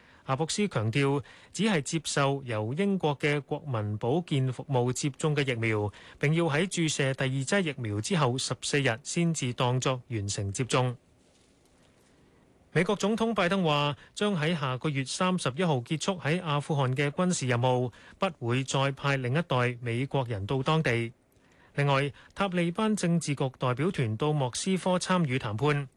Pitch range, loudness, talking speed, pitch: 125-165 Hz, -29 LUFS, 245 characters per minute, 140 Hz